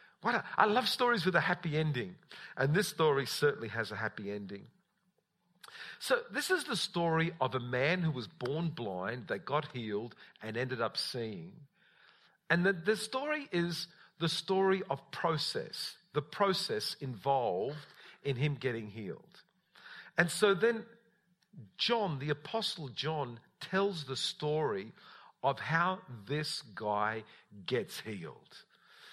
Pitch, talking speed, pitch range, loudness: 155 Hz, 140 wpm, 125-190 Hz, -34 LUFS